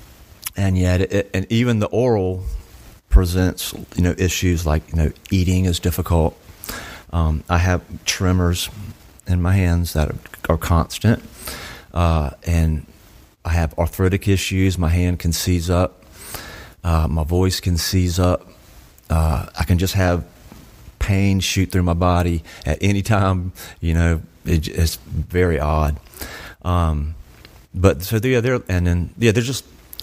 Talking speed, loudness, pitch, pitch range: 150 wpm, -20 LUFS, 90 Hz, 80-95 Hz